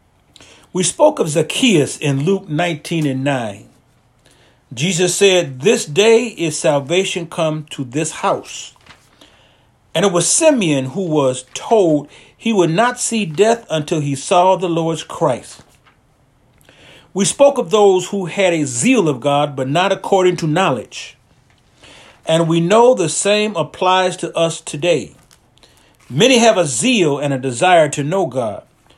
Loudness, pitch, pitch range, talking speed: -15 LUFS, 165 Hz, 140-195 Hz, 145 wpm